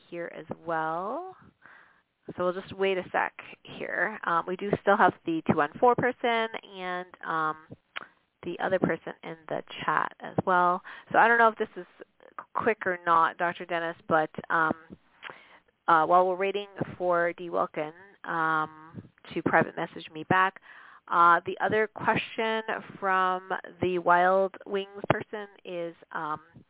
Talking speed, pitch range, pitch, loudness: 150 wpm, 170-200 Hz, 180 Hz, -27 LUFS